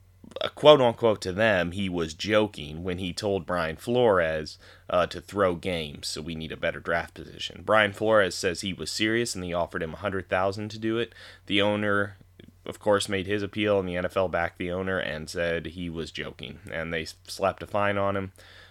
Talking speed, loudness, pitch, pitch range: 210 wpm, -27 LUFS, 95 Hz, 85-105 Hz